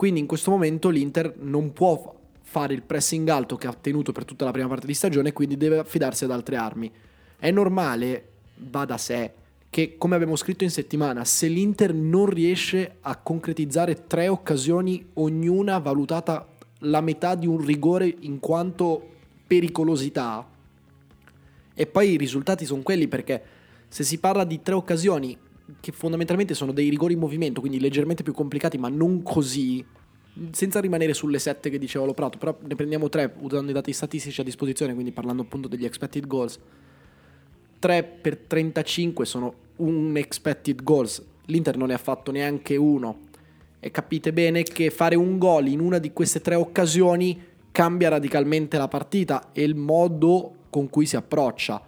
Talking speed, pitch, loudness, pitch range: 170 wpm, 150 Hz, -24 LUFS, 135-170 Hz